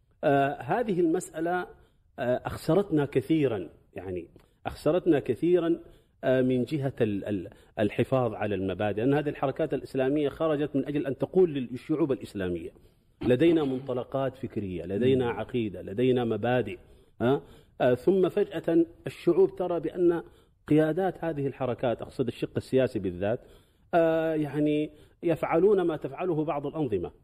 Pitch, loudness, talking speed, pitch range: 140 Hz, -28 LUFS, 105 wpm, 125-165 Hz